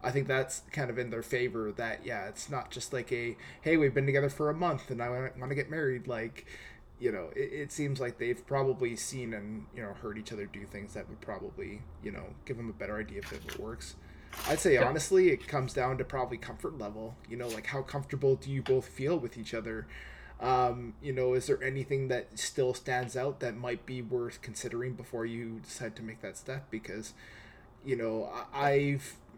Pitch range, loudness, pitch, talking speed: 115-135 Hz, -34 LUFS, 125 Hz, 225 wpm